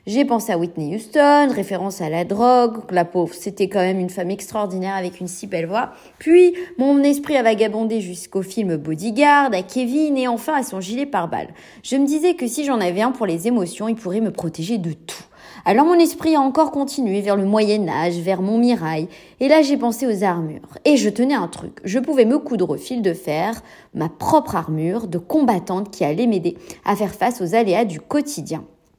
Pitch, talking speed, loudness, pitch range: 220 Hz, 210 wpm, -19 LUFS, 185-265 Hz